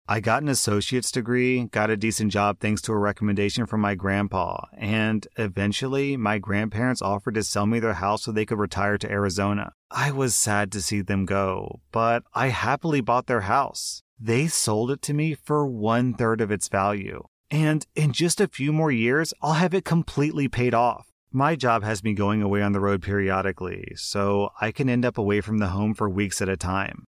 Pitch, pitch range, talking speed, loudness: 110 Hz, 100-125 Hz, 205 wpm, -24 LUFS